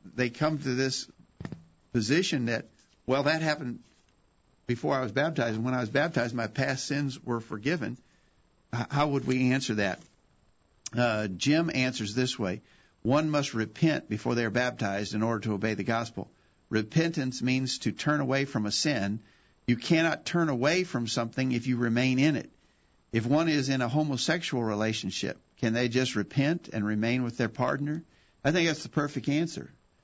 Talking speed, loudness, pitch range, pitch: 175 wpm, -29 LUFS, 115-145 Hz, 125 Hz